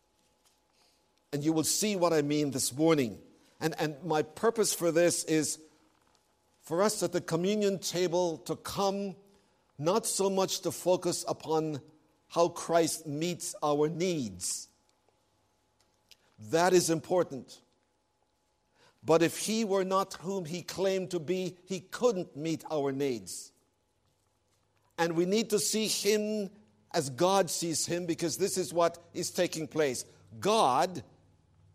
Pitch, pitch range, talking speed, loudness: 165 Hz, 145-185 Hz, 135 wpm, -30 LUFS